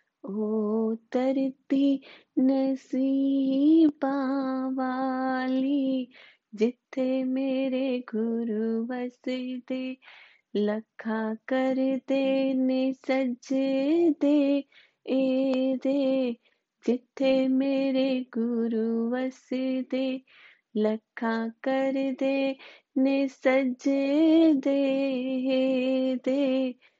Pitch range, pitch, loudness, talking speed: 255-270 Hz, 260 Hz, -27 LUFS, 50 wpm